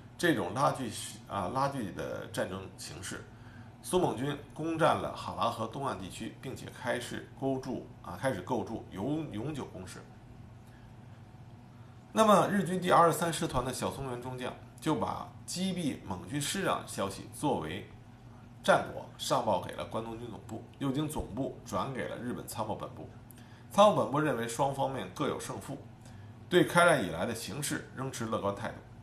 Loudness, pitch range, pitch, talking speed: -32 LUFS, 115-140 Hz, 120 Hz, 250 characters per minute